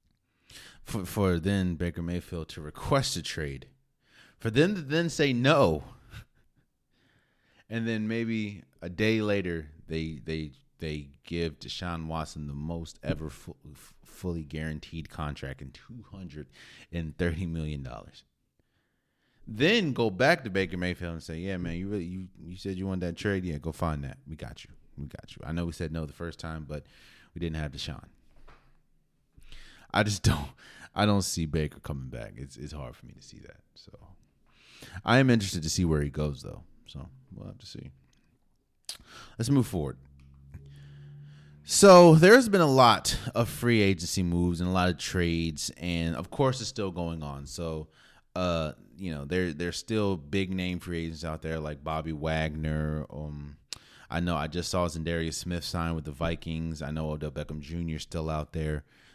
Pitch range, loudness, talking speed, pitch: 75-95 Hz, -28 LUFS, 180 wpm, 85 Hz